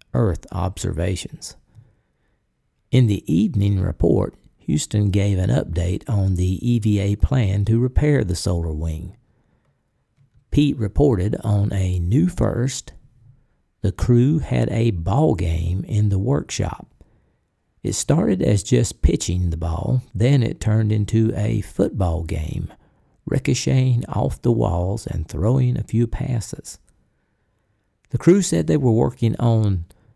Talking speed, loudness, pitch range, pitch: 125 wpm, -20 LUFS, 95-120 Hz, 110 Hz